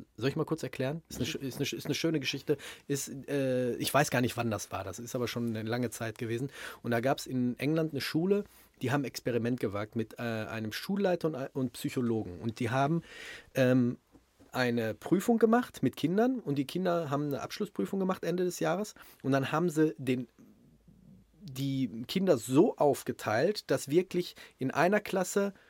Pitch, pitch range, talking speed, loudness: 135 Hz, 120-165 Hz, 190 wpm, -32 LUFS